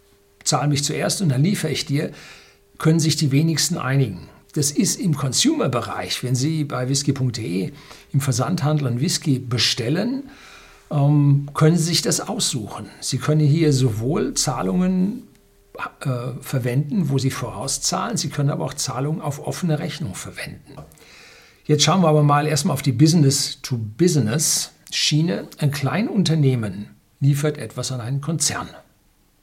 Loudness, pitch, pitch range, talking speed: -20 LUFS, 145 Hz, 130-155 Hz, 135 wpm